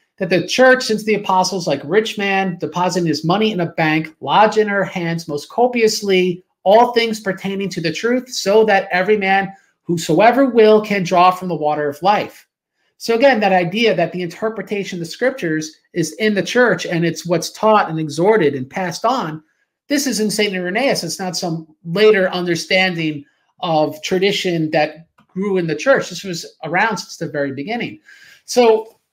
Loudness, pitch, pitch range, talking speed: -17 LUFS, 190 Hz, 170-215 Hz, 180 wpm